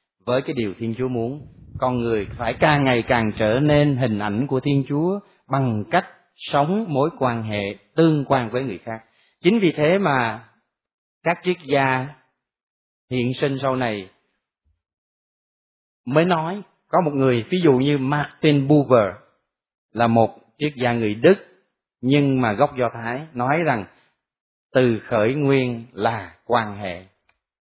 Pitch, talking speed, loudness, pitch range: 130 Hz, 150 wpm, -21 LUFS, 115-145 Hz